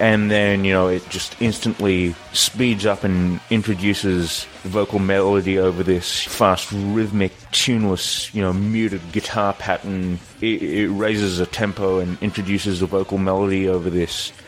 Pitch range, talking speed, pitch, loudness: 95-105 Hz, 145 wpm, 100 Hz, -20 LUFS